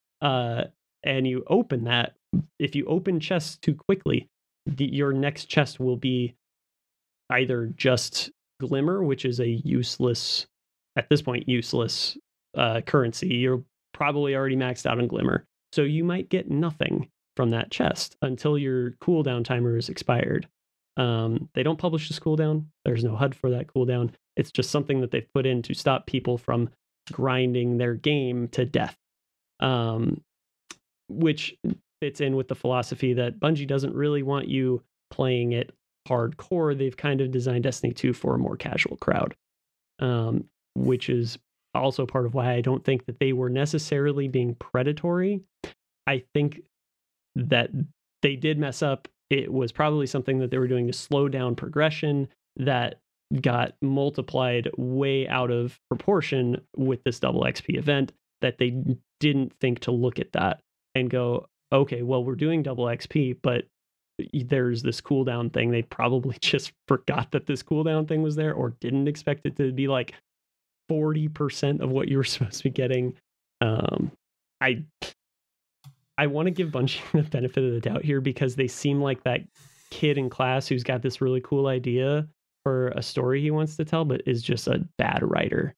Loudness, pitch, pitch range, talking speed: -26 LUFS, 130 Hz, 125-145 Hz, 170 wpm